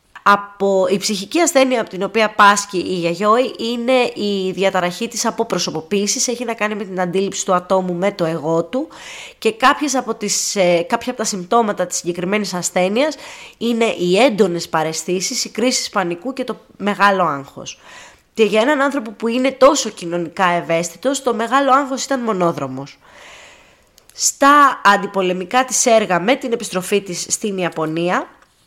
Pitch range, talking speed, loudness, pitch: 180-245 Hz, 155 wpm, -17 LUFS, 205 Hz